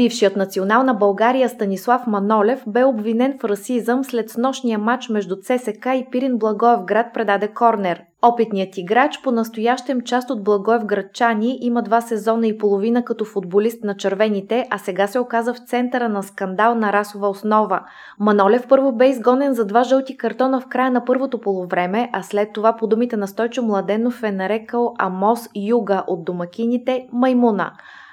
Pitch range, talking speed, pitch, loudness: 205-245 Hz, 160 wpm, 230 Hz, -19 LUFS